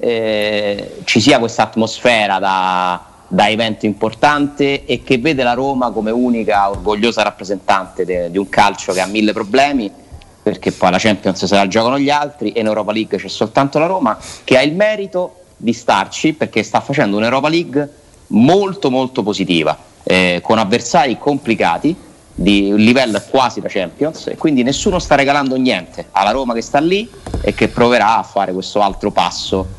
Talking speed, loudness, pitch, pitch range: 175 wpm, -15 LUFS, 110 Hz, 100-135 Hz